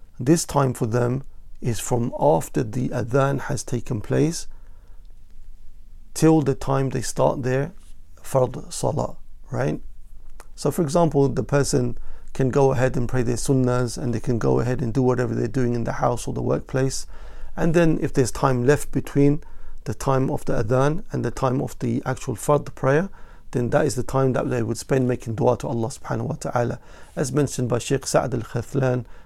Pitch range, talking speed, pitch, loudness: 120-140 Hz, 190 wpm, 130 Hz, -23 LUFS